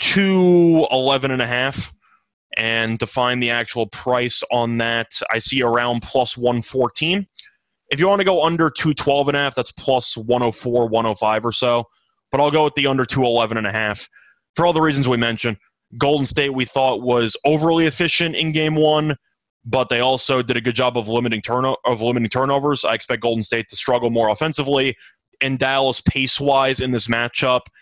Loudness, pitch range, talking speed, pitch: -18 LUFS, 120-140 Hz, 170 wpm, 125 Hz